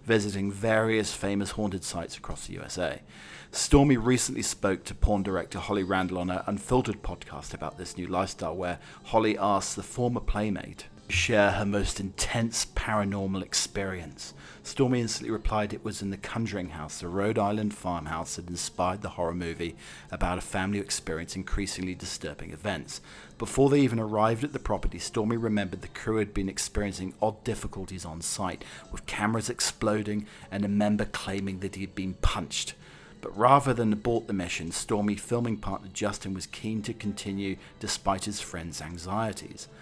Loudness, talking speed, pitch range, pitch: -29 LUFS, 165 wpm, 90-110 Hz, 100 Hz